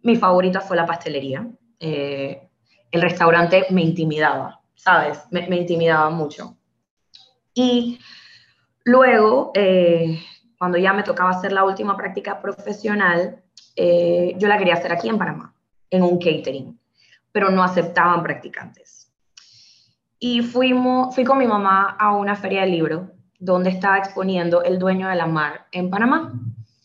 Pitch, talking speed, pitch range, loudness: 185 Hz, 145 wpm, 170-205 Hz, -19 LUFS